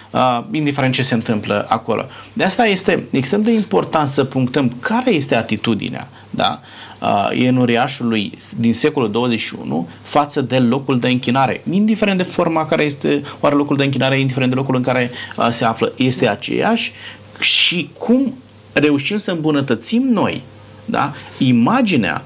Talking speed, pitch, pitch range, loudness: 150 wpm, 130 Hz, 120-160 Hz, -17 LUFS